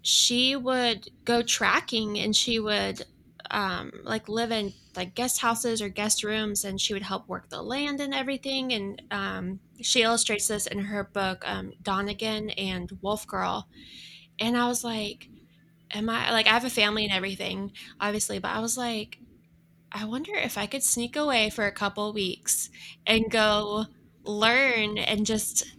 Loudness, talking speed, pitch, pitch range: -26 LUFS, 170 wpm, 215 Hz, 200-235 Hz